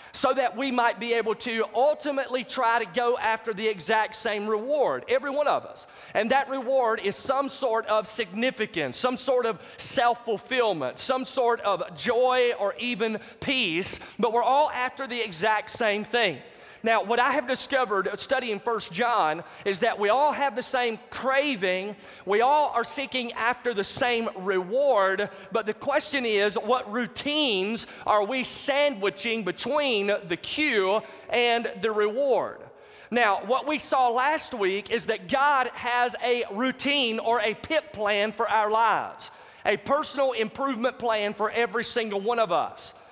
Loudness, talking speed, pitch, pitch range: -26 LUFS, 160 wpm, 235 Hz, 215-260 Hz